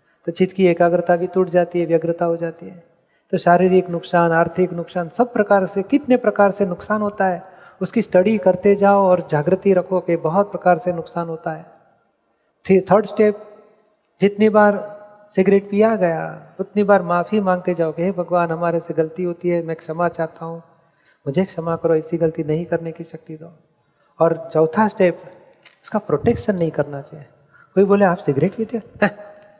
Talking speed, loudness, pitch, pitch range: 180 wpm, -18 LUFS, 175 Hz, 165-200 Hz